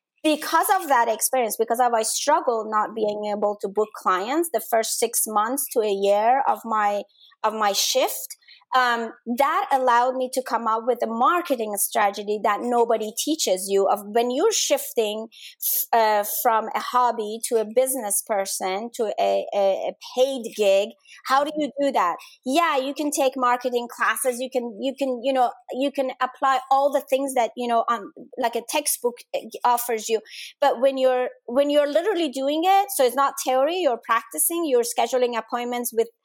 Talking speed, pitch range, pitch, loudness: 180 wpm, 220-275 Hz, 245 Hz, -22 LUFS